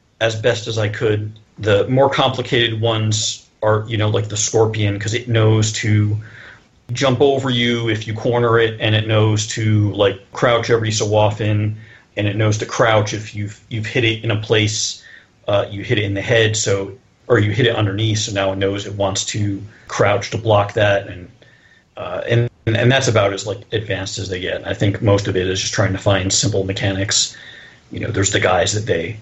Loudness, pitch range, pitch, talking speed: -17 LUFS, 100-115 Hz, 110 Hz, 210 wpm